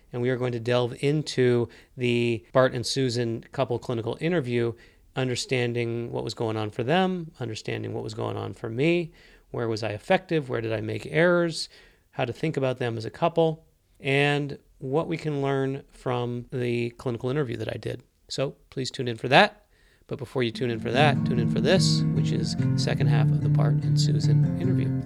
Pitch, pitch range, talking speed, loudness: 130 Hz, 115-150 Hz, 205 wpm, -26 LUFS